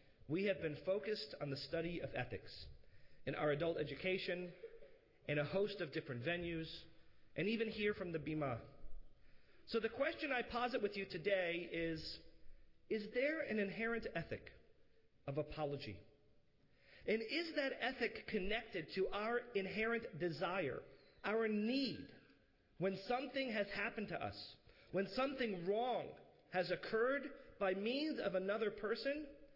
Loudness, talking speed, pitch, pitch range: -42 LUFS, 140 wpm, 195 Hz, 160-230 Hz